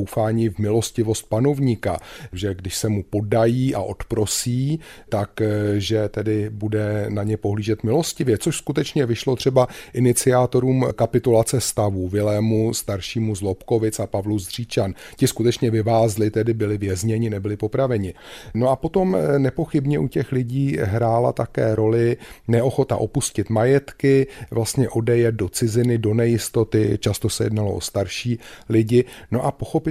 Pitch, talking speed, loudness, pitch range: 115 Hz, 135 wpm, -21 LUFS, 105-125 Hz